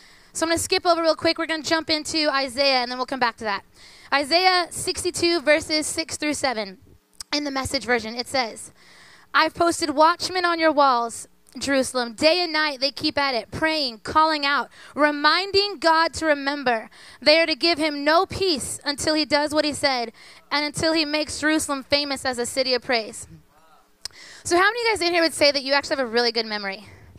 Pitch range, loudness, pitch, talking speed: 265-325 Hz, -21 LUFS, 300 Hz, 210 wpm